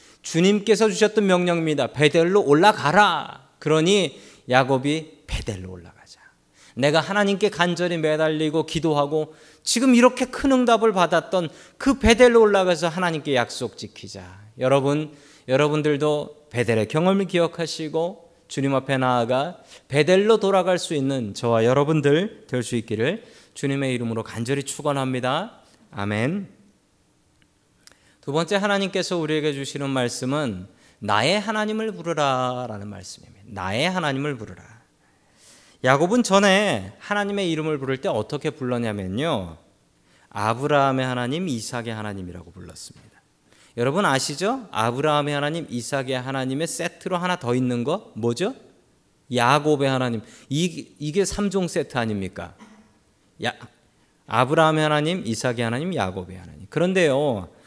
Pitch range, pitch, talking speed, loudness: 120-175 Hz, 150 Hz, 315 characters per minute, -22 LUFS